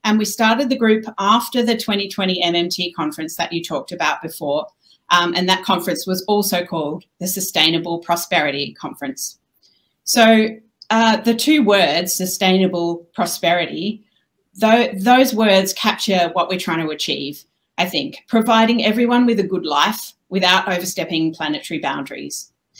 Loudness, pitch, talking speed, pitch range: -17 LUFS, 185 Hz, 140 wpm, 170-220 Hz